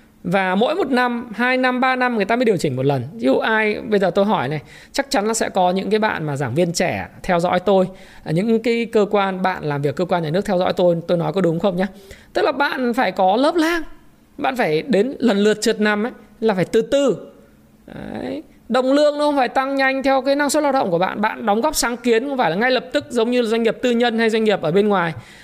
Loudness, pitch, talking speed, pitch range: -19 LUFS, 220 Hz, 275 wpm, 185-250 Hz